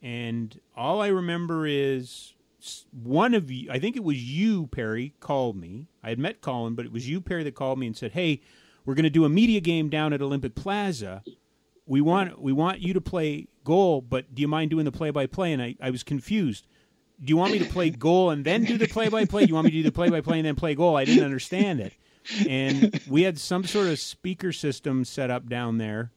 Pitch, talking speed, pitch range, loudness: 150 Hz, 250 wpm, 130-180 Hz, -25 LUFS